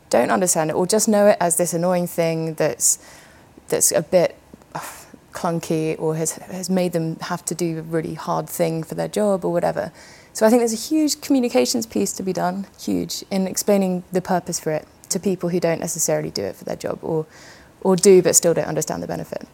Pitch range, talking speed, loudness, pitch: 165-195 Hz, 220 wpm, -20 LUFS, 180 Hz